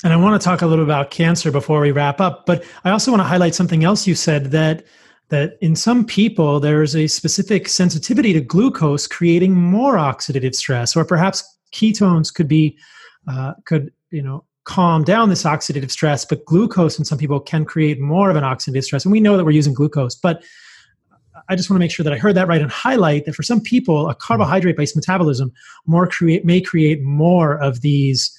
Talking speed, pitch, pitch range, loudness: 215 wpm, 160 Hz, 145-185 Hz, -16 LUFS